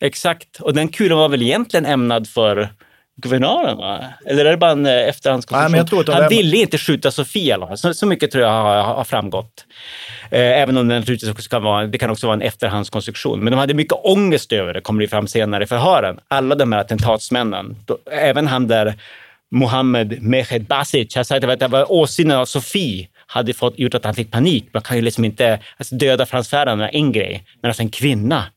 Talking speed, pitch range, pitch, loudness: 190 wpm, 110-140 Hz, 125 Hz, -17 LUFS